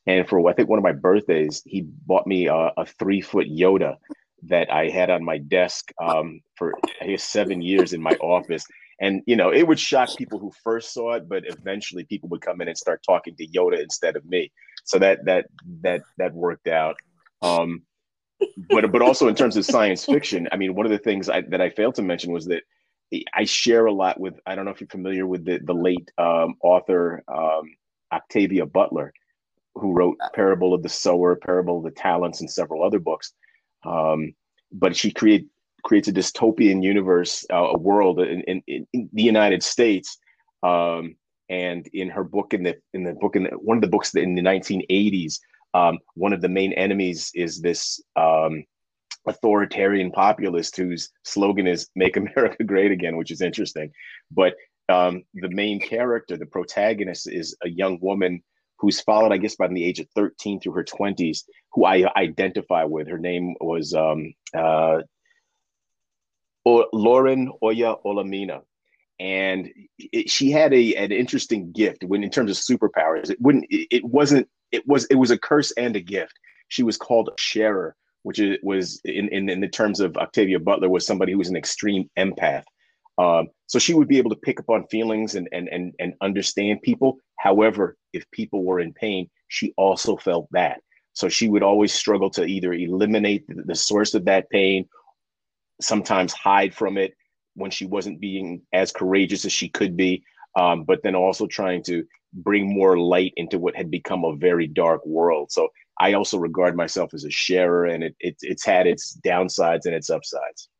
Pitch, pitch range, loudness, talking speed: 95 Hz, 90-110 Hz, -22 LUFS, 190 wpm